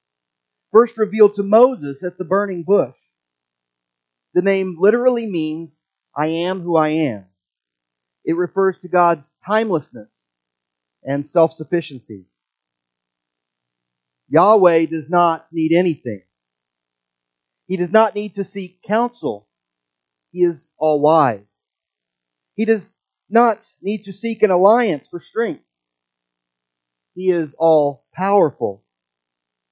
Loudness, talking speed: -18 LUFS, 105 wpm